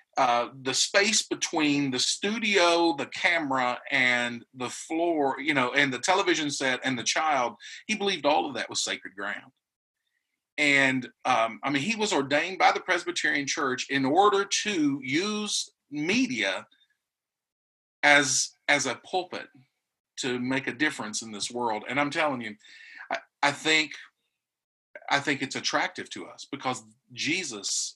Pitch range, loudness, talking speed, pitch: 130-200 Hz, -26 LUFS, 145 wpm, 145 Hz